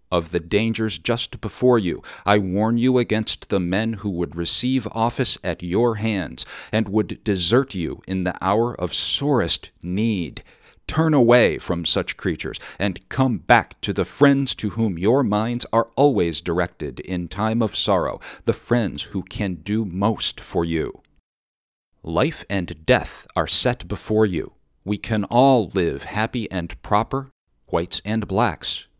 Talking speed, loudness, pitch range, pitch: 155 wpm, -22 LUFS, 90-115 Hz, 105 Hz